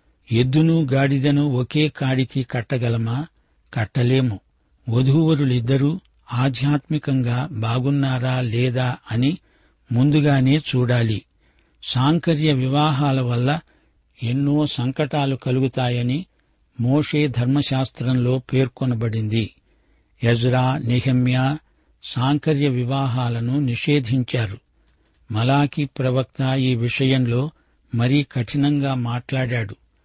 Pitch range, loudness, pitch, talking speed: 125-145 Hz, -21 LUFS, 130 Hz, 70 wpm